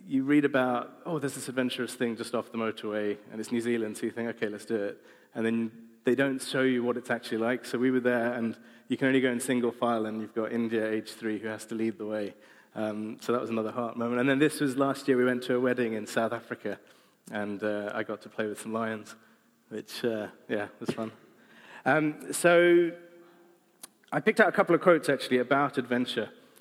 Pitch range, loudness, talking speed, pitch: 110-135 Hz, -29 LUFS, 235 wpm, 120 Hz